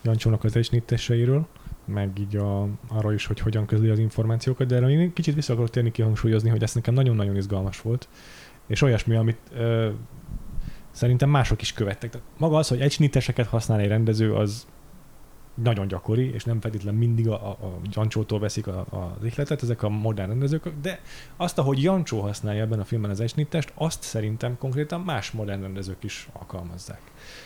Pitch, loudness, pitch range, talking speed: 115 Hz, -25 LUFS, 105-130 Hz, 175 wpm